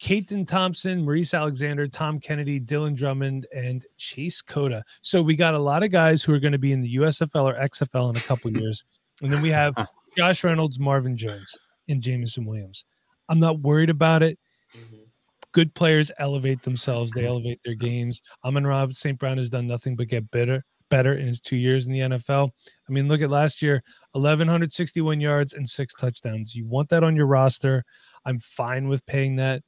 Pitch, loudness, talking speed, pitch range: 135 Hz, -23 LUFS, 195 wpm, 125-155 Hz